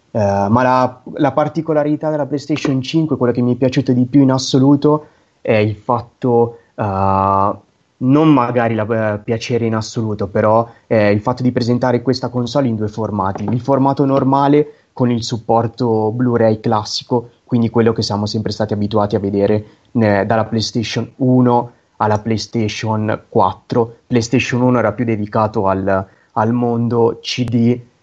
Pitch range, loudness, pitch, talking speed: 110-125 Hz, -16 LUFS, 120 Hz, 155 wpm